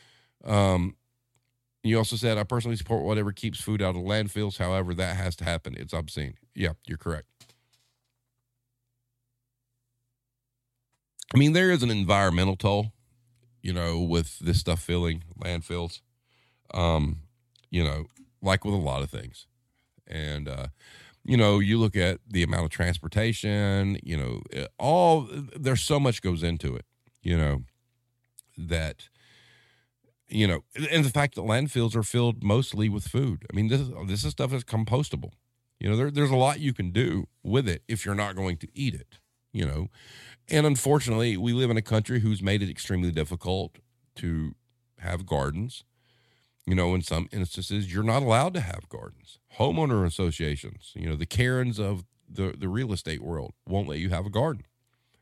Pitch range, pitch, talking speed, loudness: 90-120 Hz, 110 Hz, 170 wpm, -27 LUFS